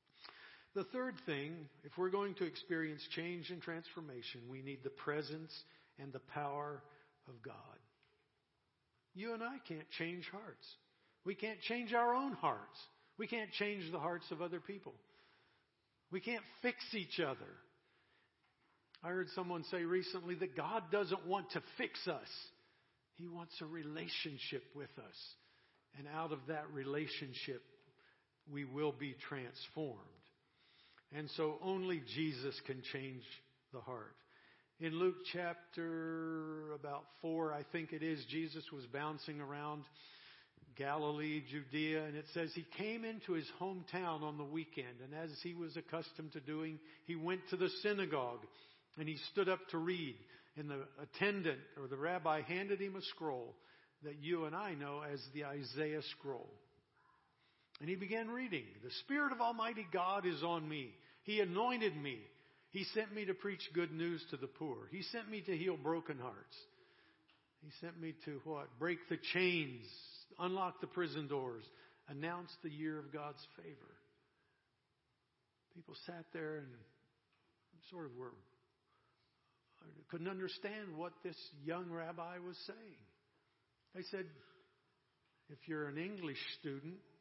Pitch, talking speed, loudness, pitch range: 160 Hz, 150 wpm, -43 LUFS, 145-180 Hz